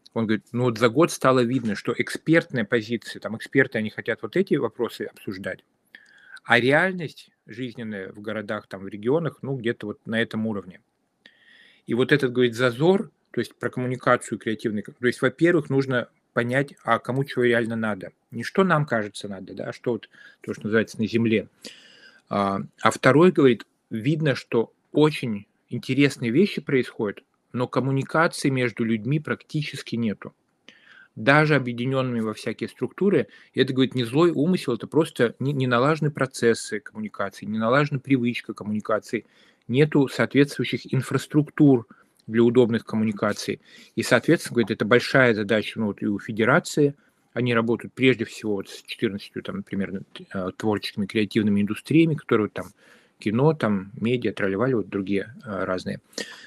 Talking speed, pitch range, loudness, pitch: 155 wpm, 110-140 Hz, -24 LUFS, 120 Hz